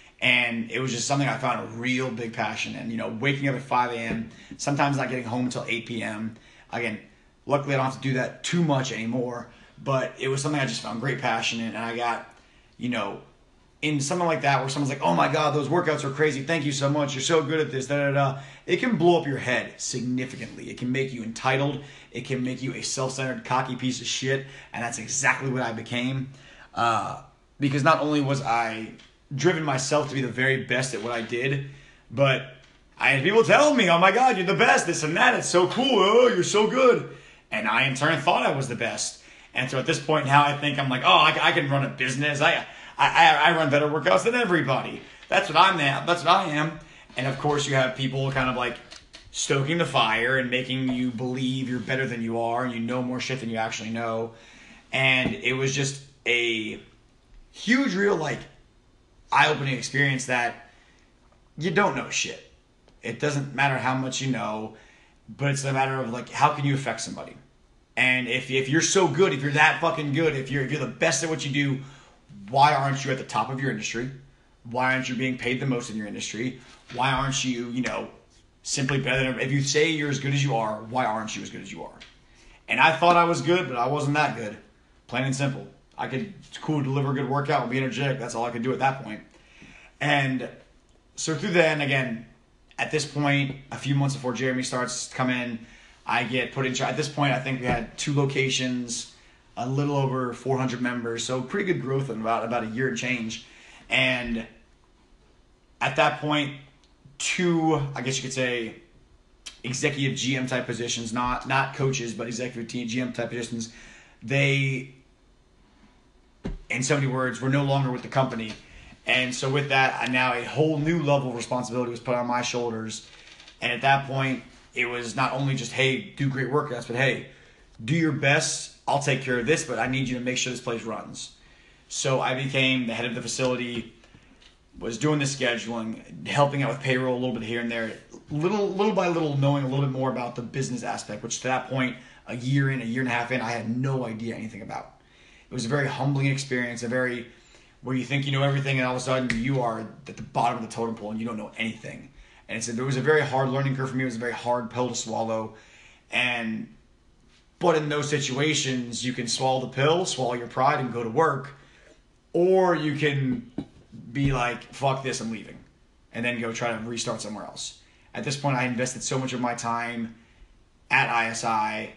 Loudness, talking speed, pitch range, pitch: -25 LUFS, 220 wpm, 120-140 Hz, 130 Hz